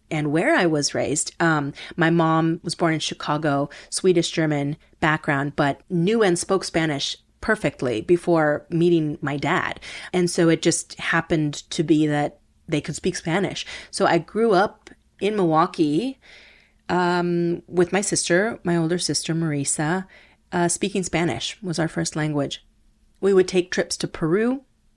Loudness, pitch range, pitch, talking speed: -22 LUFS, 155-180 Hz, 170 Hz, 155 wpm